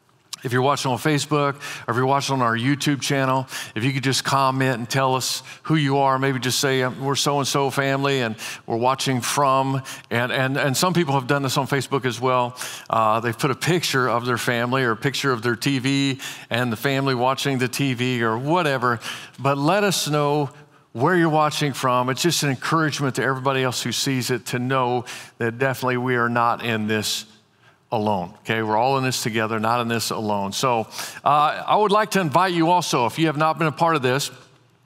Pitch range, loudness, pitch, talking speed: 125-140 Hz, -21 LUFS, 135 Hz, 215 wpm